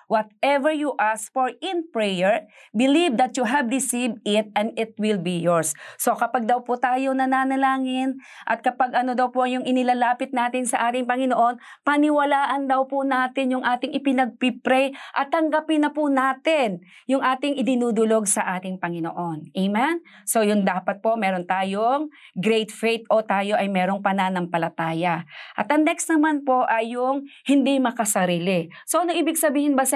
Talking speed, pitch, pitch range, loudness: 160 wpm, 250 Hz, 215-275 Hz, -22 LUFS